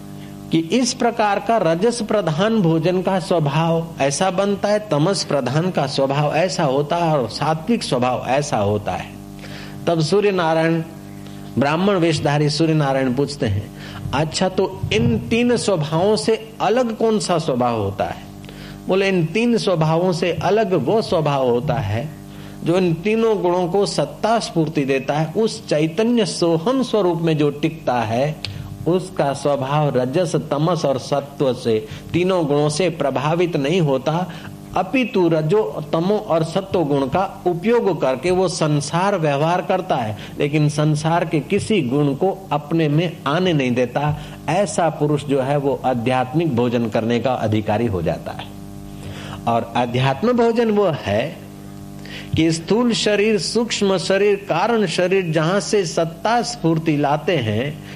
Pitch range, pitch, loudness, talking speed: 140-190 Hz, 165 Hz, -19 LUFS, 145 wpm